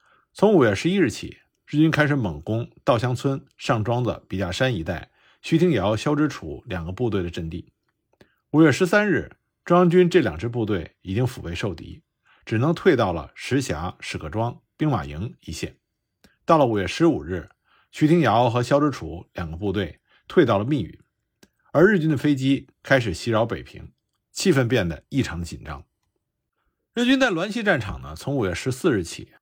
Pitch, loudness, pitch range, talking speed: 120 Hz, -22 LUFS, 95-150 Hz, 265 characters per minute